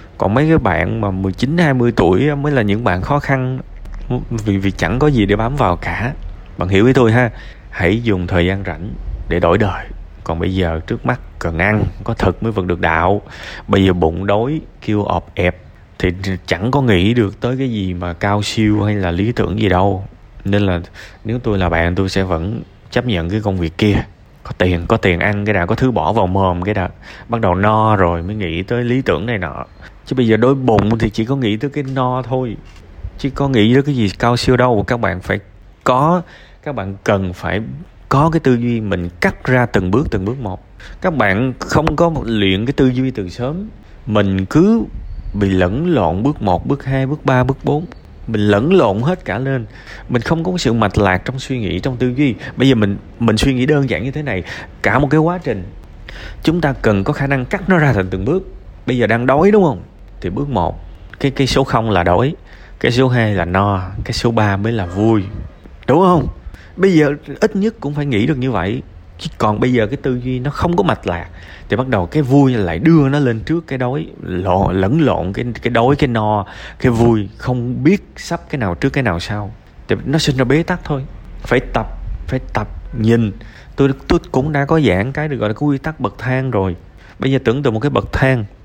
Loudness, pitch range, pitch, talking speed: -16 LUFS, 95-130 Hz, 110 Hz, 230 wpm